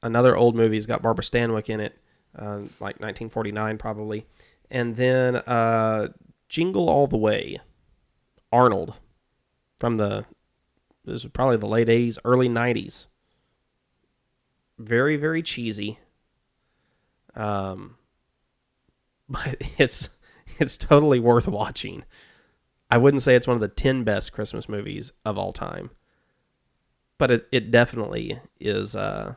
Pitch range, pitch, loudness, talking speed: 105-125 Hz, 115 Hz, -23 LUFS, 125 wpm